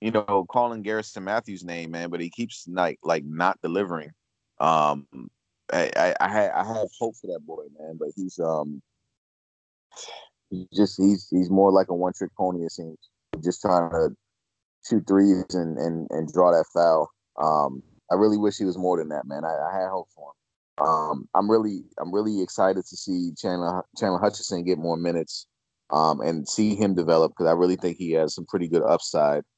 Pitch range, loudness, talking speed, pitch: 85-100 Hz, -24 LUFS, 195 wpm, 90 Hz